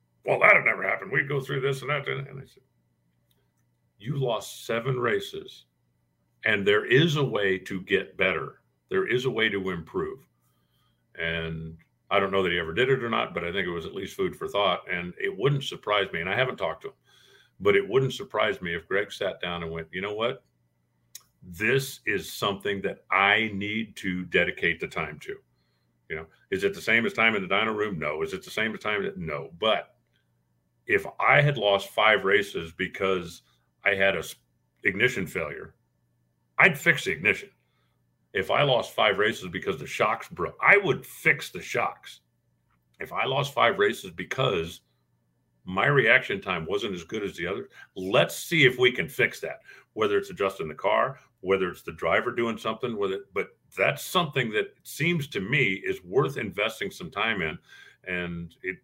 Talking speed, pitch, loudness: 195 wpm, 95 Hz, -26 LUFS